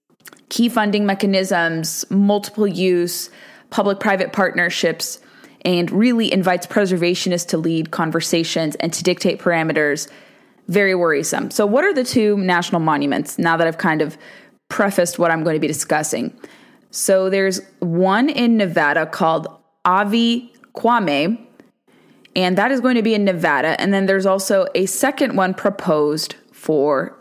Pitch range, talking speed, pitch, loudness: 170-210 Hz, 145 wpm, 190 Hz, -18 LUFS